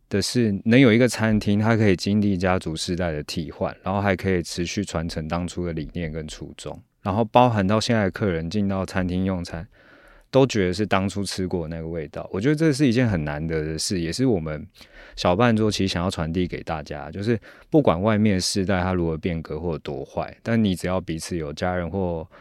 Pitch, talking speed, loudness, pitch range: 95 Hz, 320 characters per minute, -23 LUFS, 85-105 Hz